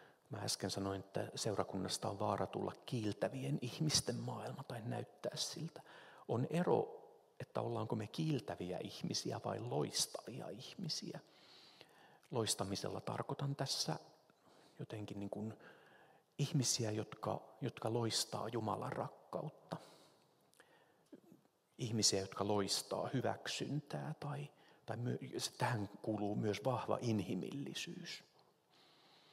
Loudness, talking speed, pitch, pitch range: -41 LUFS, 100 wpm, 120 Hz, 105-145 Hz